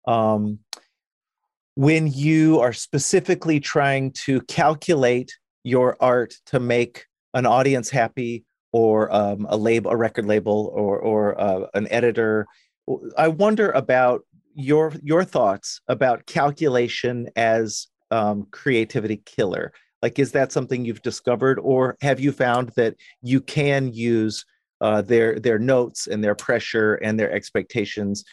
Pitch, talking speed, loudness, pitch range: 120 Hz, 135 wpm, -21 LUFS, 110-135 Hz